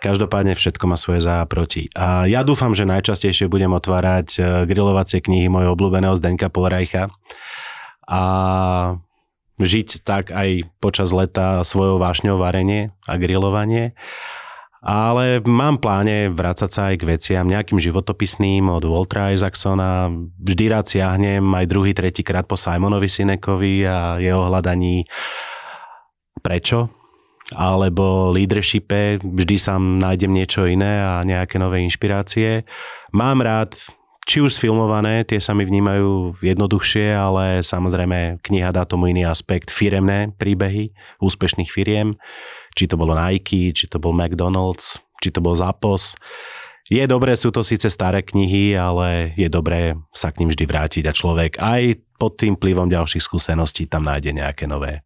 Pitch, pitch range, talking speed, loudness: 95 Hz, 90-100 Hz, 140 wpm, -18 LUFS